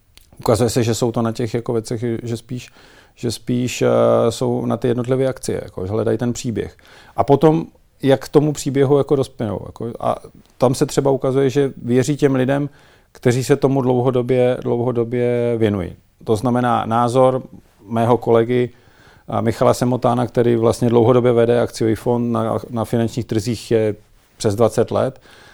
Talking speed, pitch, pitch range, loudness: 160 wpm, 120 Hz, 115-130 Hz, -18 LUFS